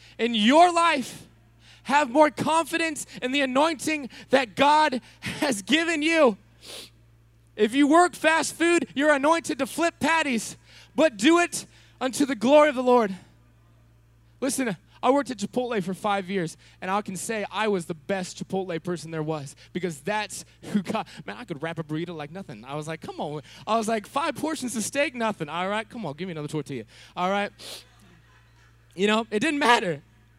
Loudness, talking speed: -24 LUFS, 185 wpm